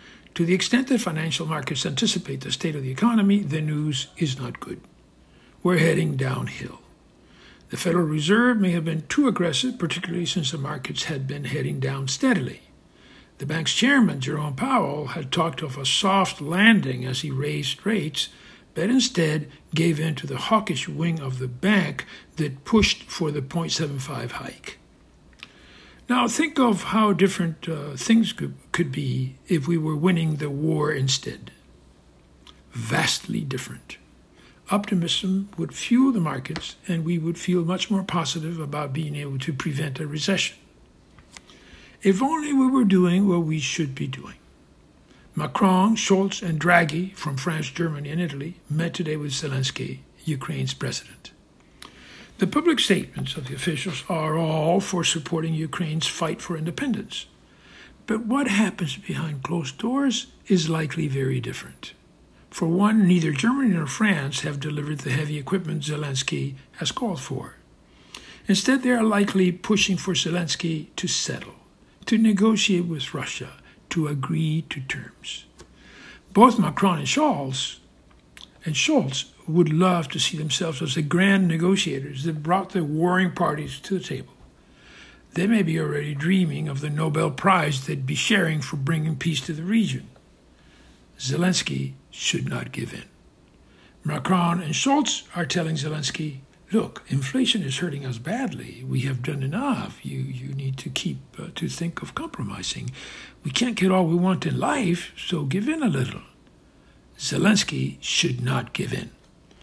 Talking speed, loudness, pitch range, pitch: 150 wpm, -24 LUFS, 145-185 Hz, 165 Hz